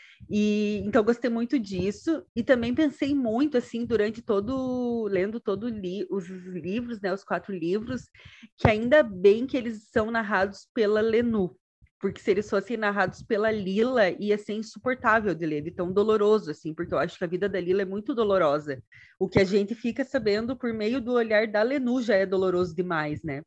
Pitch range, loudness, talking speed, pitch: 190-235 Hz, -26 LUFS, 190 wpm, 210 Hz